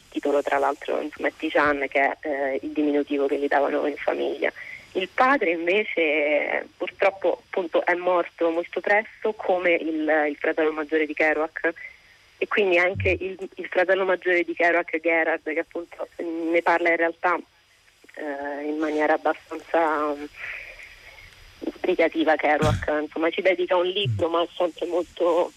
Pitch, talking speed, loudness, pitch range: 160 Hz, 150 wpm, -24 LUFS, 150-175 Hz